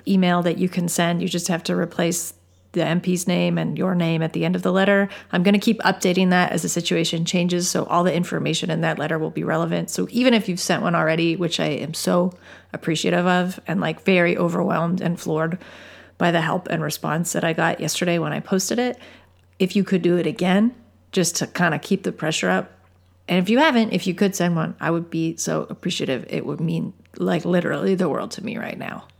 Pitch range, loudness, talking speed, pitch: 165-190 Hz, -21 LUFS, 230 wpm, 175 Hz